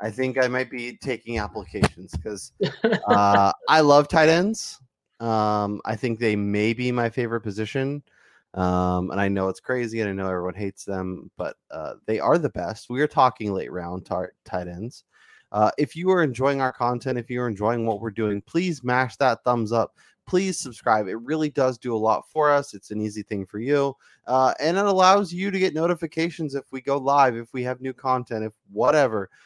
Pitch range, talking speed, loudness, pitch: 105-140 Hz, 205 wpm, -23 LUFS, 120 Hz